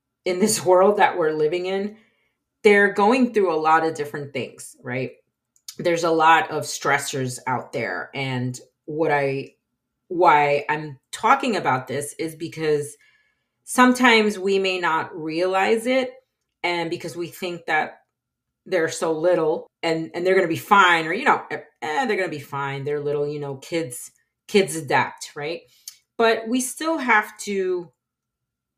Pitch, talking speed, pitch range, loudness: 170 Hz, 155 wpm, 145-200 Hz, -21 LUFS